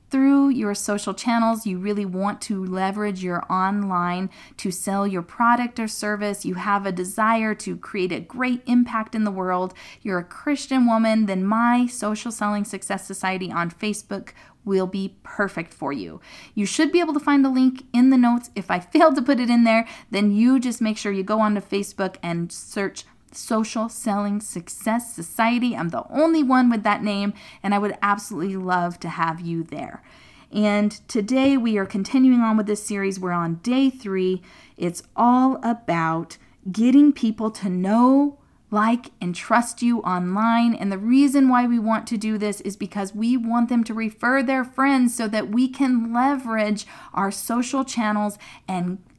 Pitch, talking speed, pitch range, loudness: 215 Hz, 180 wpm, 195-240 Hz, -22 LUFS